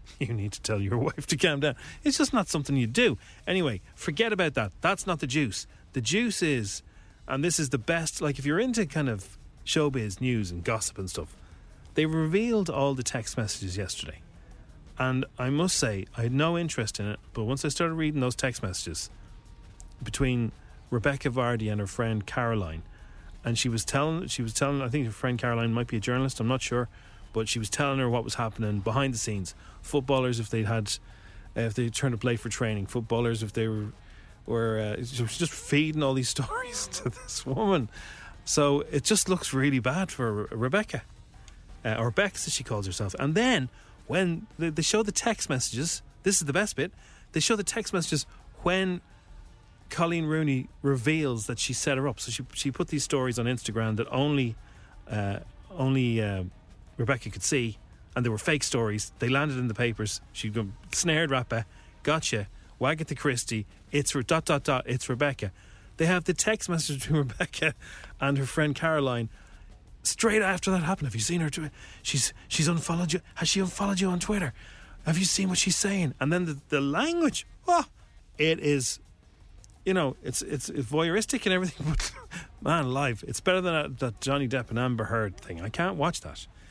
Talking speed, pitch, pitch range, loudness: 200 wpm, 130 Hz, 110-155 Hz, -28 LUFS